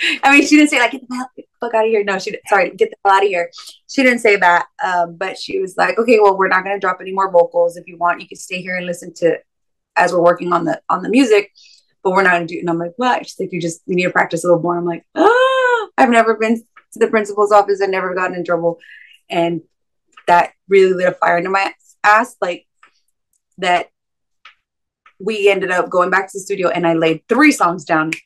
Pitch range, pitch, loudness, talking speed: 175-225 Hz, 190 Hz, -15 LUFS, 255 wpm